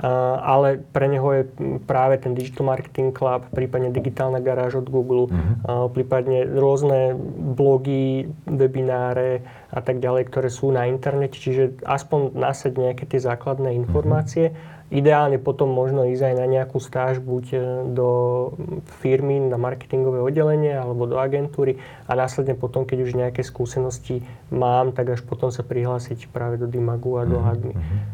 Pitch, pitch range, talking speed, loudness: 130 Hz, 125-135 Hz, 145 wpm, -22 LUFS